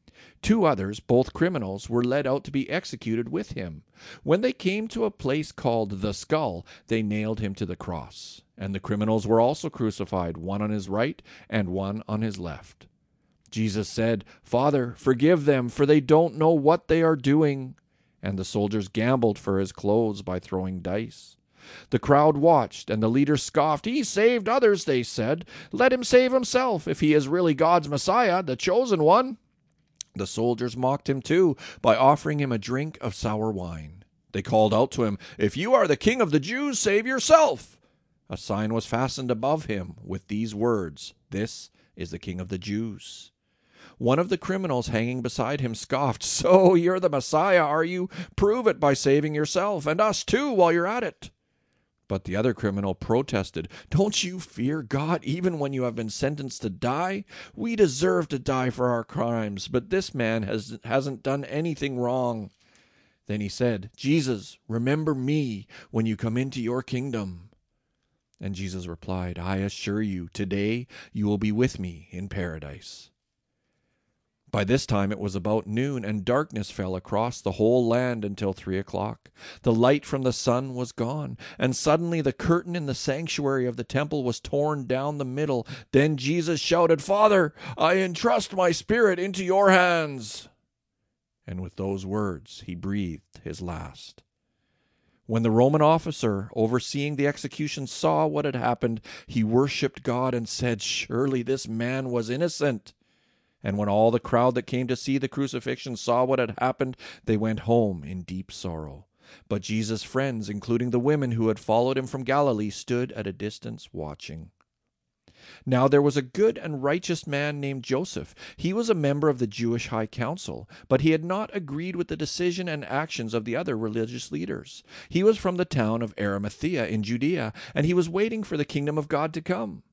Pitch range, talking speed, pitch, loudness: 110-155 Hz, 180 wpm, 125 Hz, -25 LUFS